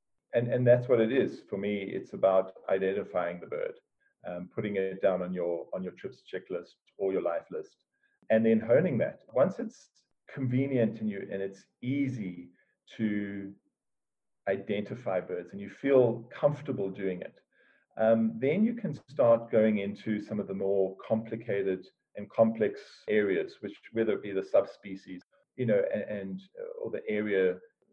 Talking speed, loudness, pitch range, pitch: 165 wpm, -30 LUFS, 95-125 Hz, 110 Hz